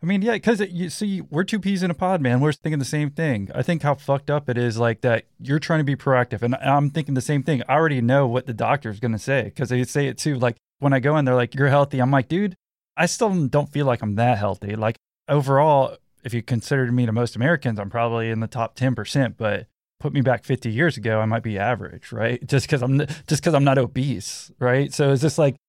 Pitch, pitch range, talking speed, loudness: 135 Hz, 120-150 Hz, 265 wpm, -22 LUFS